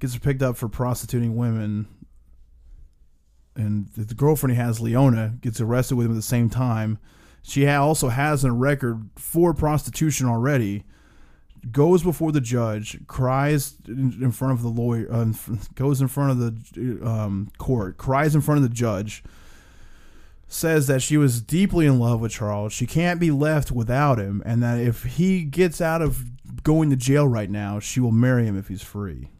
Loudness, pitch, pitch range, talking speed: -22 LUFS, 120 Hz, 110-140 Hz, 175 wpm